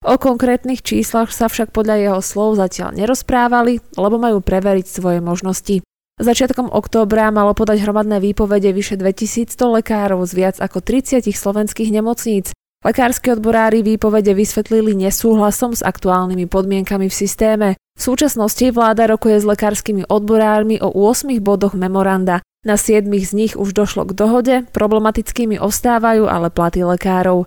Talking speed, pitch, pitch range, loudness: 140 wpm, 210 Hz, 195-225 Hz, -15 LUFS